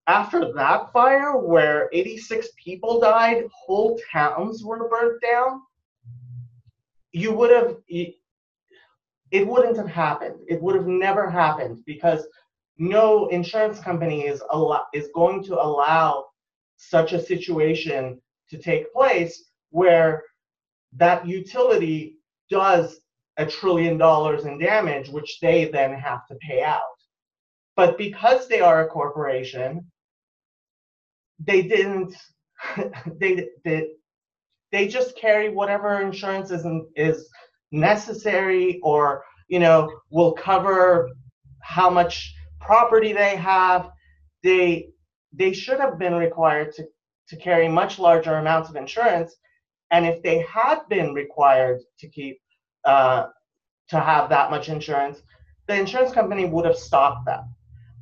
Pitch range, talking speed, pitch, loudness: 150-200 Hz, 125 wpm, 170 Hz, -21 LUFS